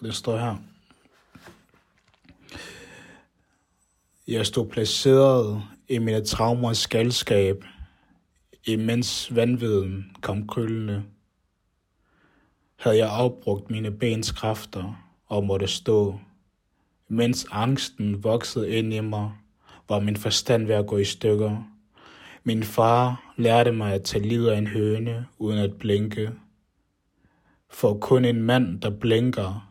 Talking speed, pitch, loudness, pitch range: 110 wpm, 110 Hz, -24 LUFS, 100-115 Hz